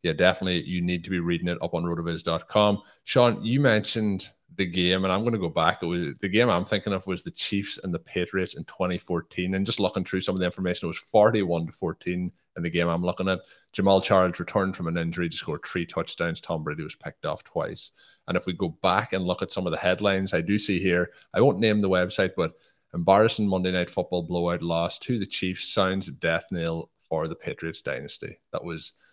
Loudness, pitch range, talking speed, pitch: -26 LUFS, 90-100 Hz, 230 wpm, 95 Hz